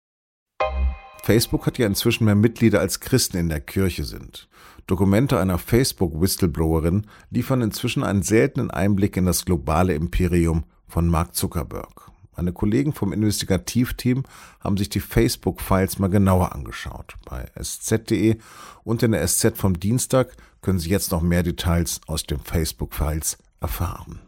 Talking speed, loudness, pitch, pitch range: 140 wpm, -22 LUFS, 95 Hz, 85-110 Hz